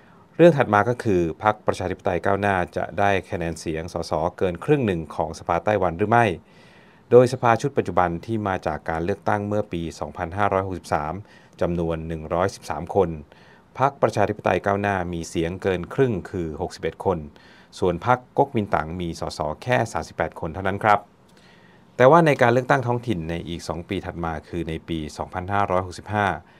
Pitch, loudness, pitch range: 95 Hz, -23 LUFS, 85-105 Hz